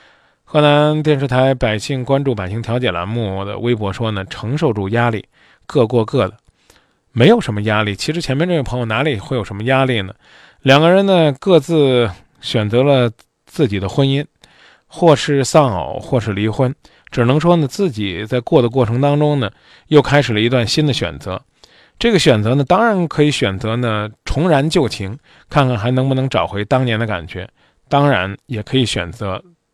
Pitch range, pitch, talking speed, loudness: 110-145 Hz, 125 Hz, 270 characters per minute, -16 LUFS